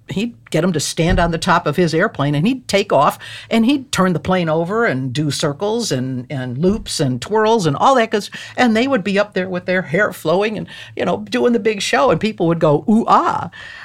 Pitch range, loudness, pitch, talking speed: 160-225 Hz, -17 LUFS, 190 Hz, 245 wpm